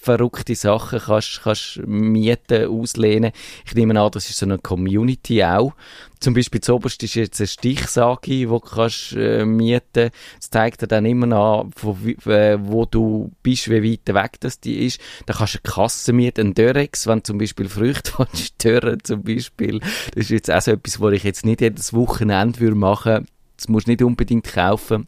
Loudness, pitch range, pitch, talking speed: -19 LUFS, 105-120 Hz, 115 Hz, 185 wpm